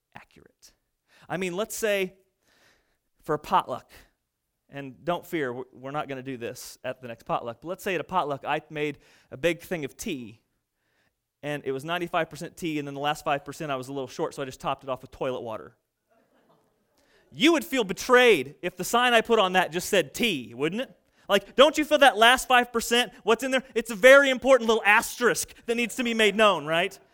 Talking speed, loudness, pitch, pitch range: 215 wpm, -24 LUFS, 180 Hz, 140-230 Hz